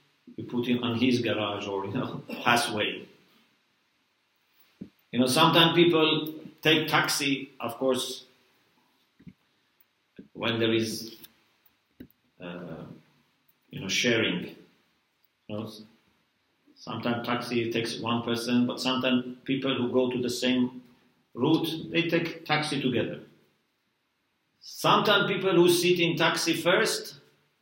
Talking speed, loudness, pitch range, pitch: 115 wpm, -26 LUFS, 115-155 Hz, 125 Hz